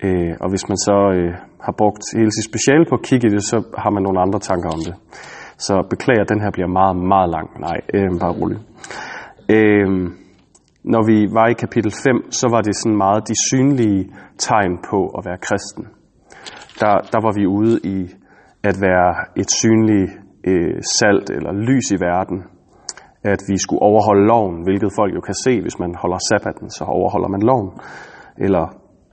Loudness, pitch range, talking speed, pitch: -17 LUFS, 95-110 Hz, 180 wpm, 100 Hz